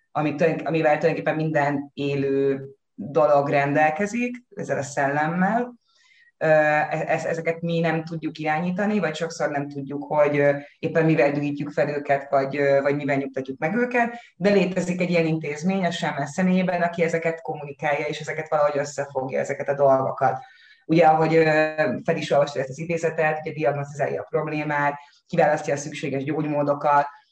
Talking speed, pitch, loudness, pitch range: 135 wpm, 155 Hz, -23 LUFS, 145-165 Hz